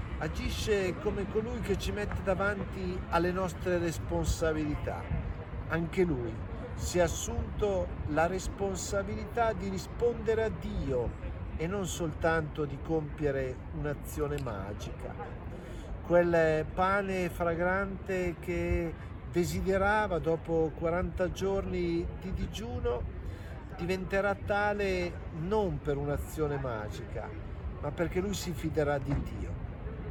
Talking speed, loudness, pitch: 100 wpm, -33 LUFS, 155 Hz